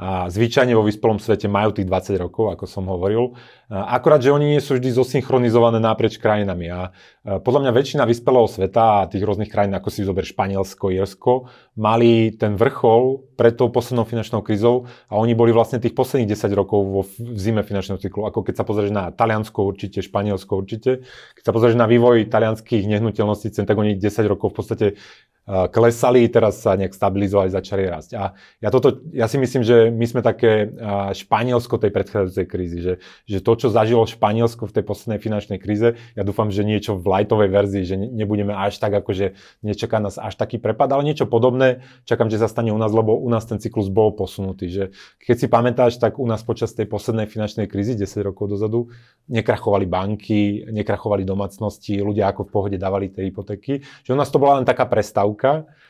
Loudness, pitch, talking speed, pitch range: -19 LUFS, 110 Hz, 190 wpm, 100-120 Hz